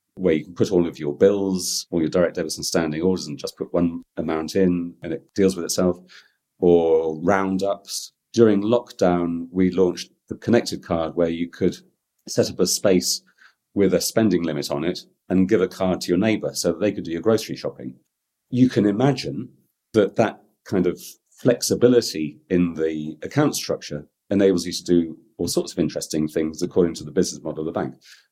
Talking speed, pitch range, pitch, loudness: 195 wpm, 80-95 Hz, 90 Hz, -22 LUFS